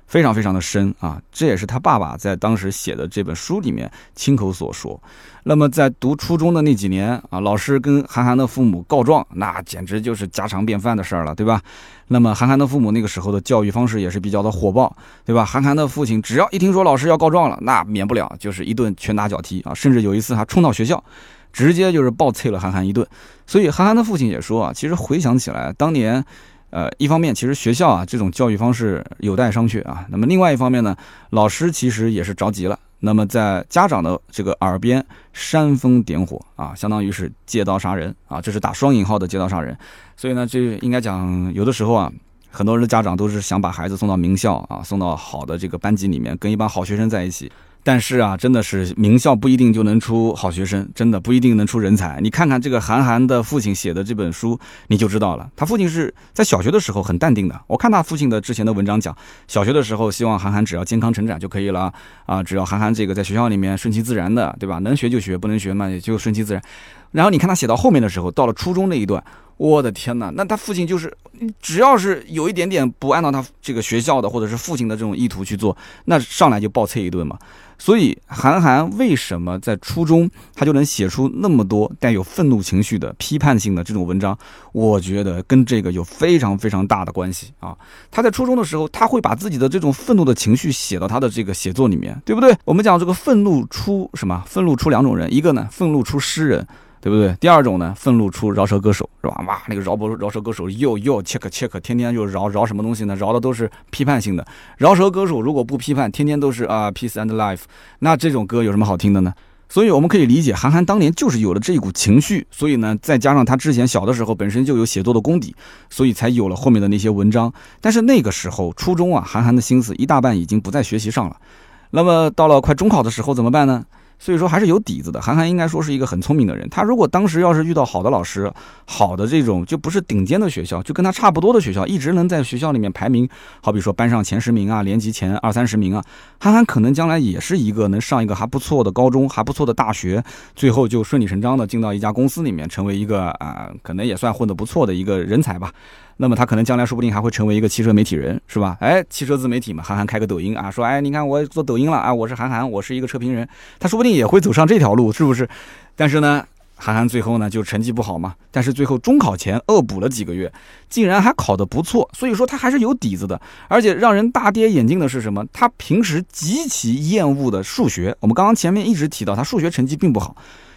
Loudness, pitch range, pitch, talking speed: -17 LUFS, 100-140 Hz, 115 Hz, 375 characters per minute